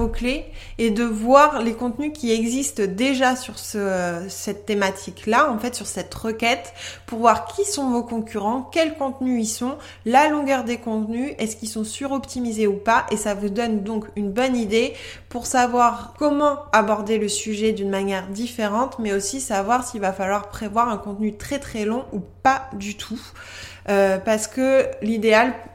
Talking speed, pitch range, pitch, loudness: 180 wpm, 215-255 Hz, 230 Hz, -22 LUFS